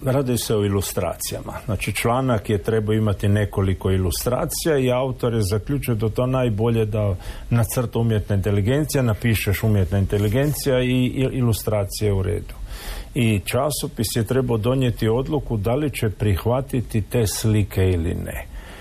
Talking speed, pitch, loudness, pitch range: 135 wpm, 110 Hz, -22 LUFS, 105-125 Hz